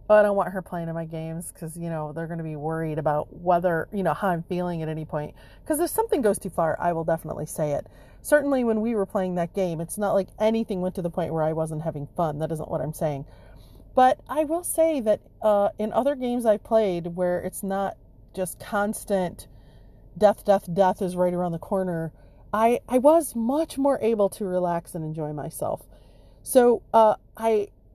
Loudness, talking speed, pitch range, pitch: -25 LUFS, 215 wpm, 160-215 Hz, 185 Hz